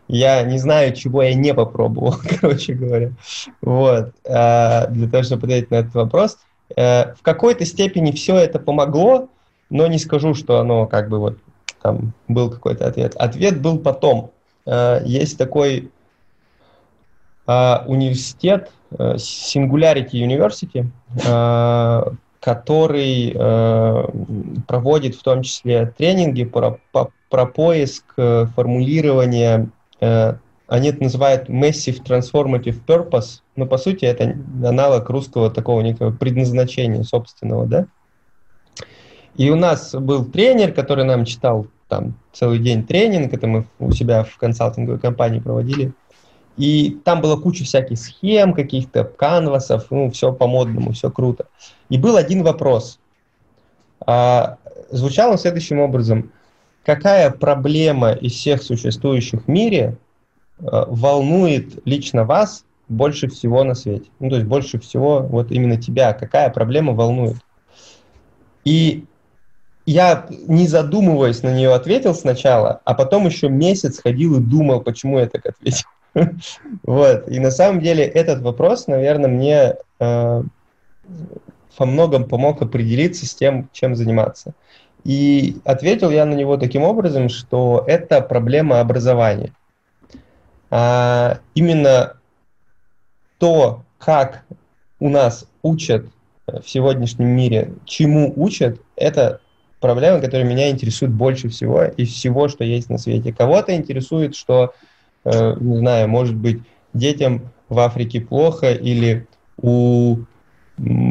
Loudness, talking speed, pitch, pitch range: -17 LUFS, 120 wpm, 130 Hz, 120-150 Hz